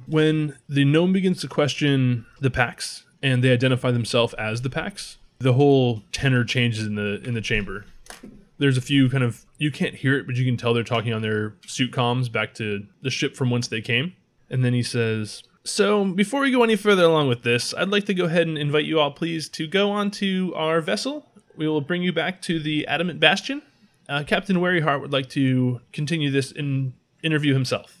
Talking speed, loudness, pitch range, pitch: 215 wpm, -22 LUFS, 125-170 Hz, 140 Hz